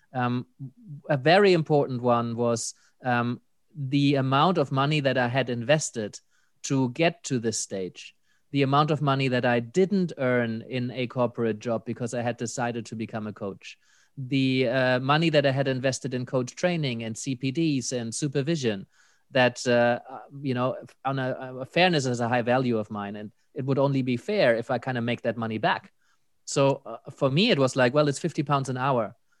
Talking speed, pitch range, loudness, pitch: 195 wpm, 120-140 Hz, -26 LUFS, 130 Hz